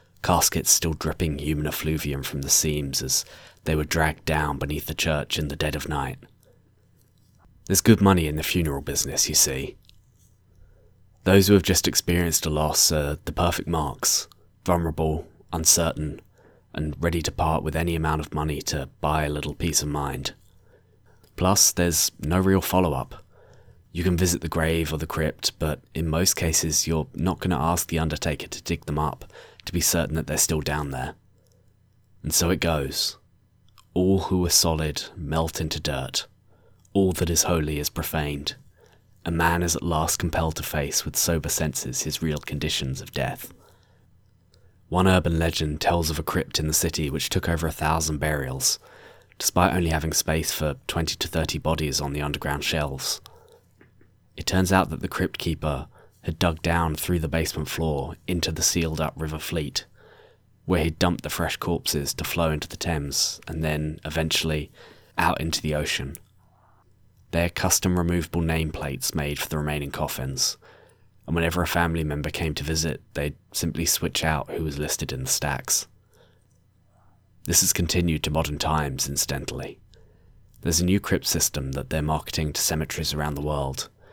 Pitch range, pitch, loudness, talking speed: 75-90 Hz, 80 Hz, -24 LUFS, 175 wpm